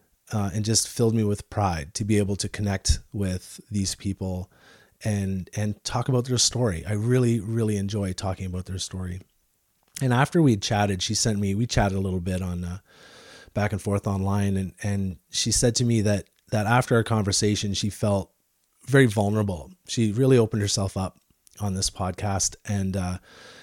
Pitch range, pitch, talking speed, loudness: 95-110 Hz, 100 Hz, 185 wpm, -25 LUFS